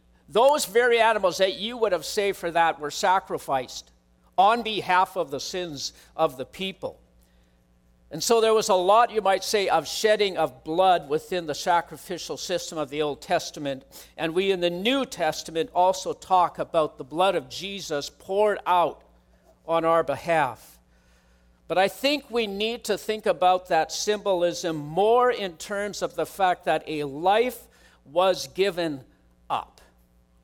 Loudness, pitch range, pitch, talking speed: -24 LUFS, 145-195 Hz, 175 Hz, 160 wpm